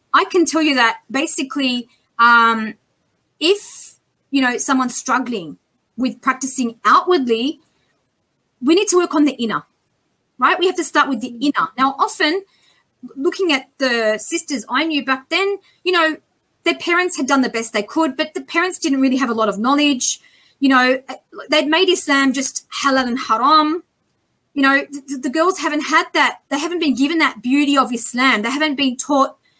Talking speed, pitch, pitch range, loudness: 180 wpm, 280 Hz, 255-330 Hz, -16 LUFS